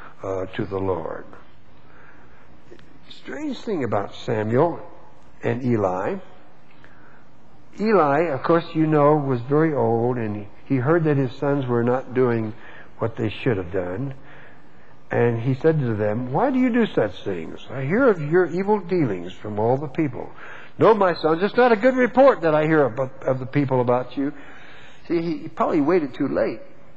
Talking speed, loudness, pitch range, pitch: 170 wpm, -22 LUFS, 115-165 Hz, 135 Hz